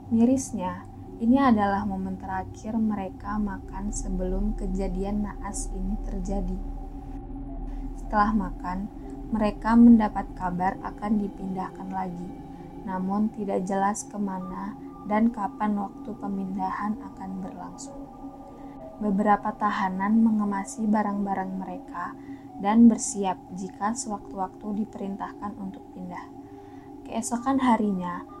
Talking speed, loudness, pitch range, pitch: 95 wpm, -27 LUFS, 190-225 Hz, 205 Hz